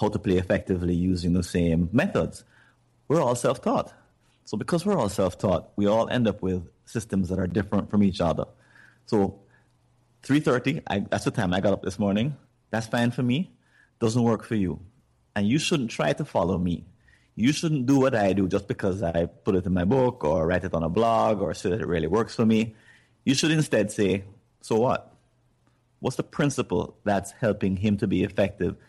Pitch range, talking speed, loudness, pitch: 90-120 Hz, 205 wpm, -25 LUFS, 100 Hz